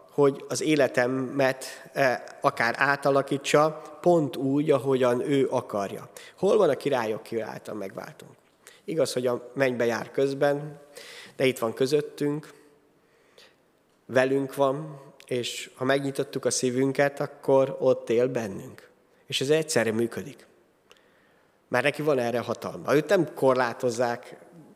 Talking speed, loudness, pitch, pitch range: 120 wpm, -26 LUFS, 135 Hz, 125-145 Hz